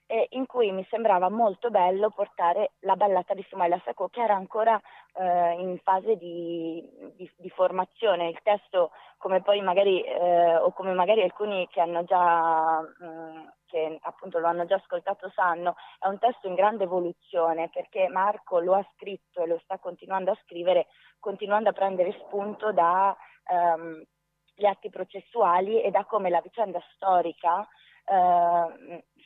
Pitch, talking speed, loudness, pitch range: 185 Hz, 155 wpm, -26 LUFS, 170-200 Hz